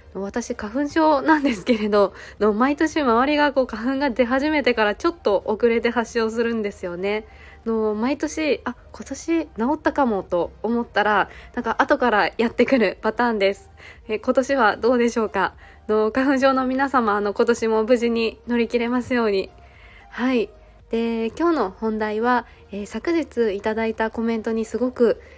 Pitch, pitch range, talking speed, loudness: 235 Hz, 220-265 Hz, 320 characters per minute, -21 LUFS